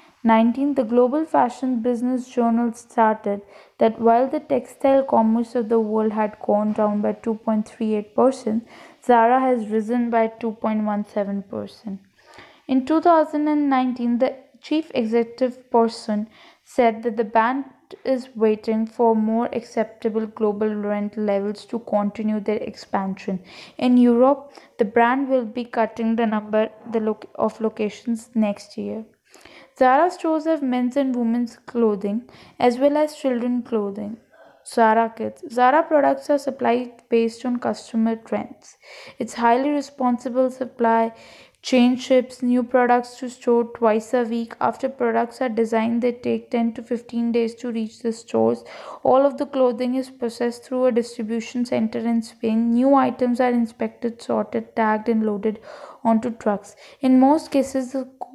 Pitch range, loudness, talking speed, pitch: 225-255 Hz, -21 LUFS, 140 wpm, 235 Hz